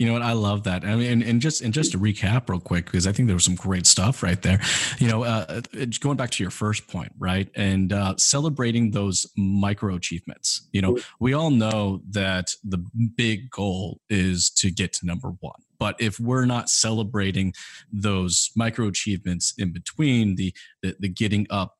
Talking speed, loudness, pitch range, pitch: 200 wpm, -23 LUFS, 95-115 Hz, 100 Hz